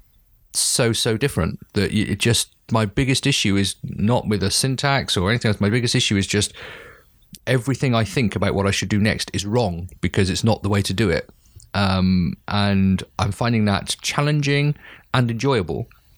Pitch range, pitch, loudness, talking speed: 100-125 Hz, 105 Hz, -20 LUFS, 180 wpm